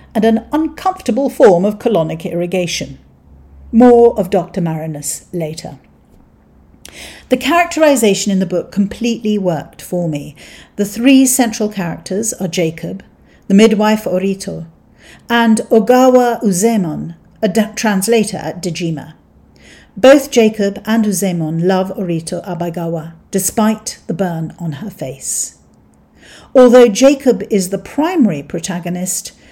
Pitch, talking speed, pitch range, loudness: 195 Hz, 115 wpm, 165-230 Hz, -14 LUFS